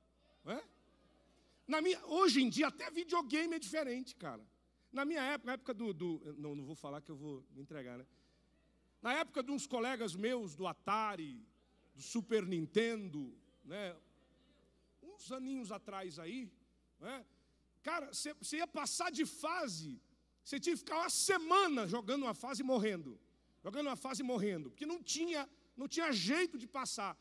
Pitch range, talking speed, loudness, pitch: 195-310 Hz, 165 wpm, -39 LUFS, 255 Hz